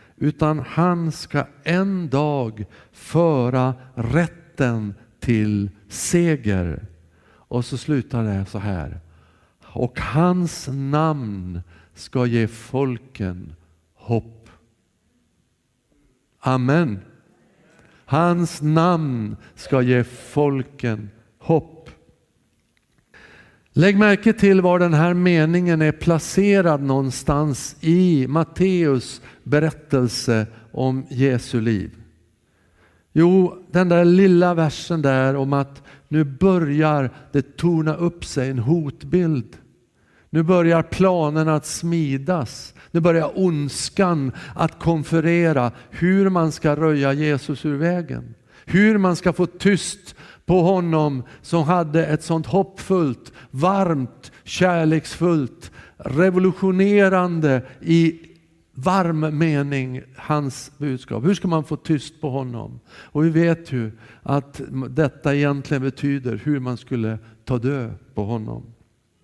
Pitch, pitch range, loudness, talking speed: 145 Hz, 120-170 Hz, -20 LUFS, 105 wpm